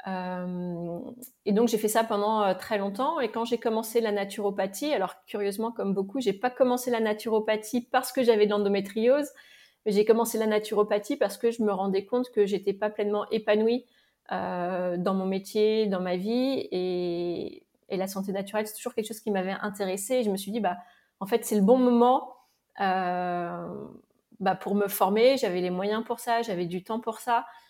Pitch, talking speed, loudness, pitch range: 215 Hz, 195 wpm, -27 LUFS, 195-235 Hz